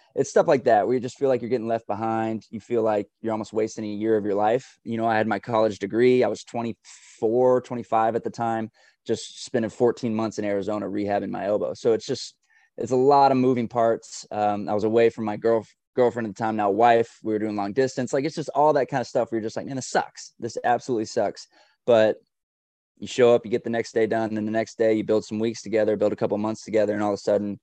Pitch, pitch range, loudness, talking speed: 110 Hz, 105-120 Hz, -24 LUFS, 265 wpm